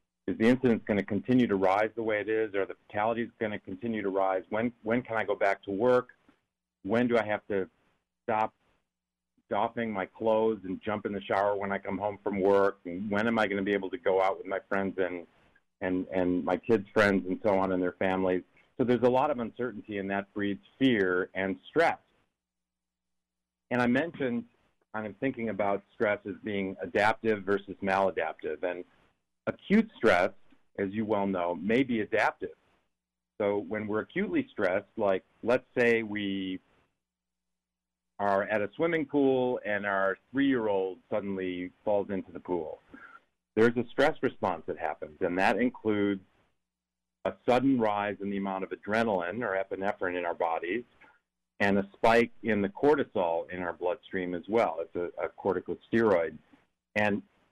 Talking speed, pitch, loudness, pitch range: 175 wpm, 100 Hz, -30 LUFS, 90-110 Hz